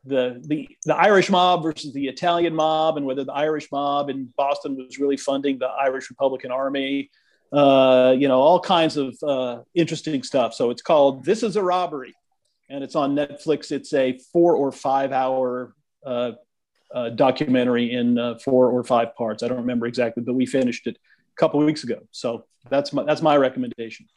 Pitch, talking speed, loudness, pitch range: 135 Hz, 190 wpm, -21 LUFS, 125-150 Hz